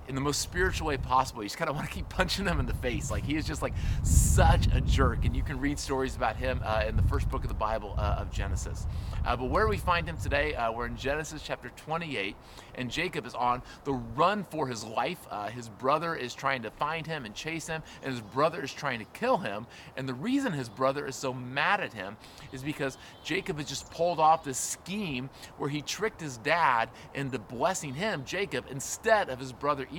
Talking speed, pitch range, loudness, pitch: 235 wpm, 110-150 Hz, -30 LUFS, 135 Hz